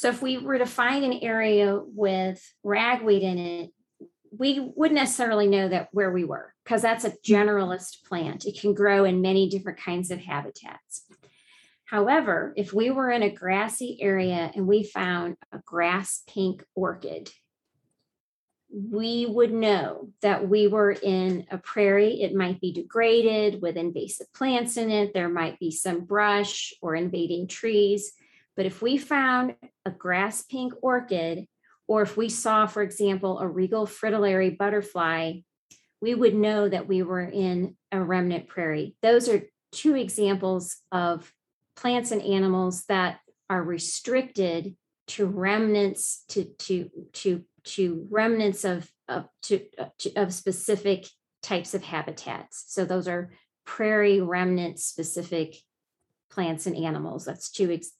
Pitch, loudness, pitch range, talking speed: 195 Hz, -26 LUFS, 180-215 Hz, 145 wpm